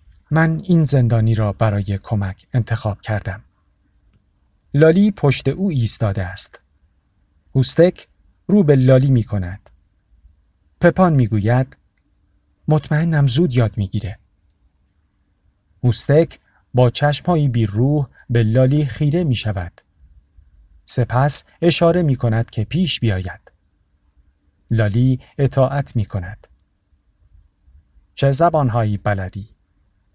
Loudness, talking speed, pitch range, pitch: -17 LUFS, 100 wpm, 90-135 Hz, 105 Hz